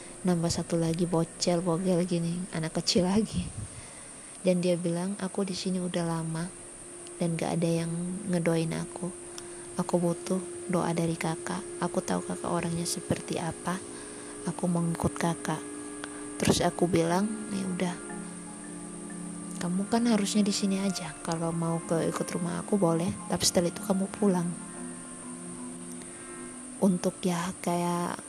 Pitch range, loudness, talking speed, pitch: 165-185 Hz, -30 LUFS, 135 wpm, 175 Hz